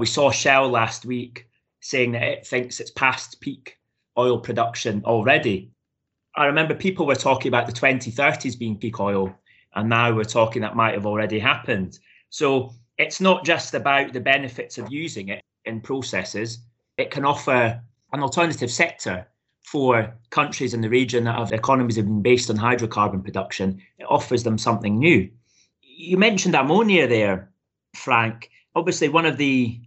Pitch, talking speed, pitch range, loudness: 120 Hz, 165 wpm, 115-135 Hz, -21 LUFS